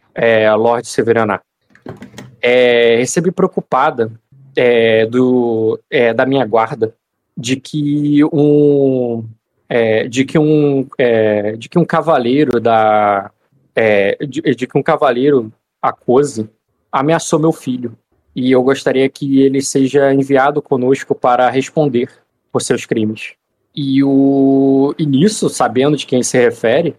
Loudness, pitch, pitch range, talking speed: -13 LUFS, 130 Hz, 115-140 Hz, 125 wpm